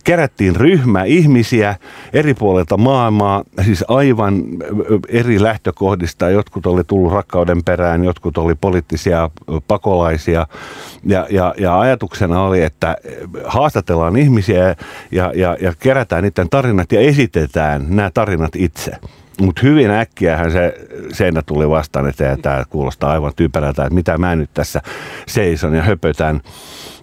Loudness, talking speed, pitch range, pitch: -15 LUFS, 130 wpm, 85-105 Hz, 90 Hz